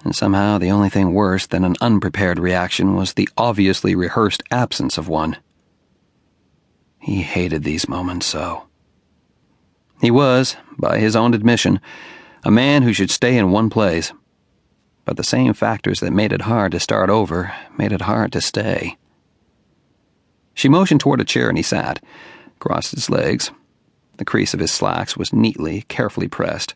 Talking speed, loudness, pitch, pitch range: 160 wpm, -18 LUFS, 100 Hz, 90-115 Hz